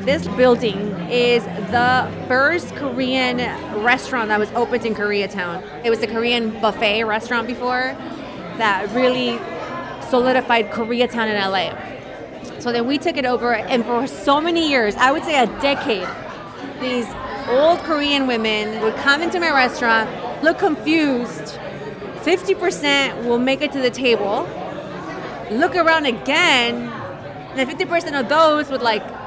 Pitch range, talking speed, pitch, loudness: 230-280 Hz, 140 wpm, 250 Hz, -19 LUFS